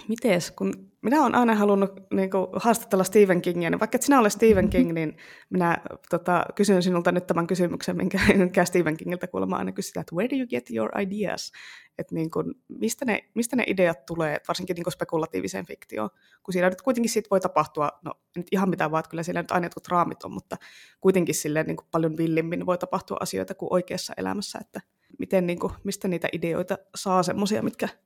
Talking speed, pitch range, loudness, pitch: 205 wpm, 170-205 Hz, -25 LUFS, 180 Hz